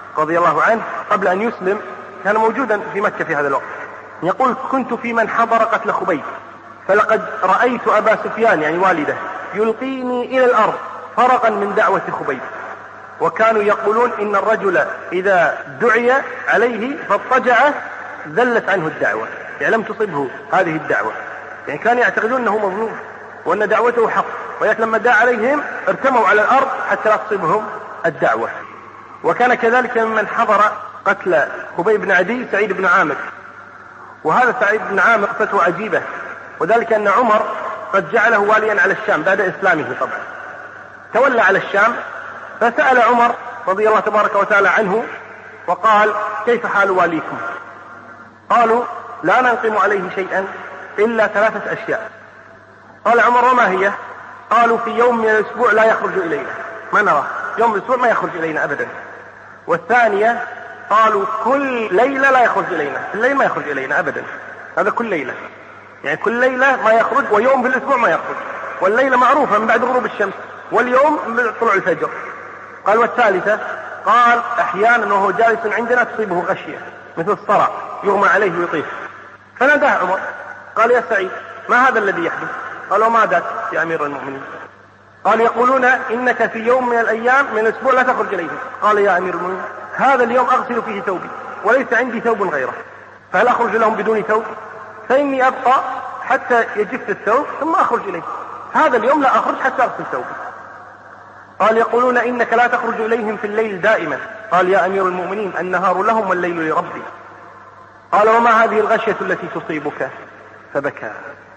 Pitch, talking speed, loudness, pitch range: 225 Hz, 145 wpm, -16 LUFS, 210-245 Hz